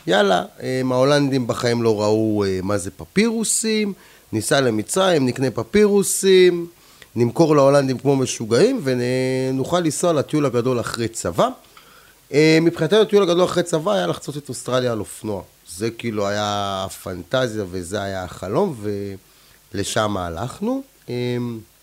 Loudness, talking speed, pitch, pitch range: -20 LUFS, 115 wpm, 130 Hz, 105-165 Hz